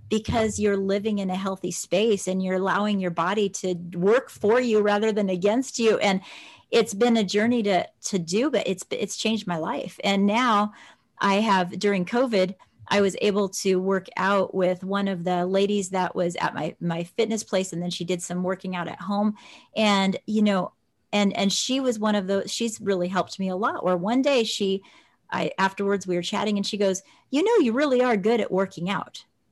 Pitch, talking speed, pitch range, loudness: 200 Hz, 210 wpm, 185-215 Hz, -24 LUFS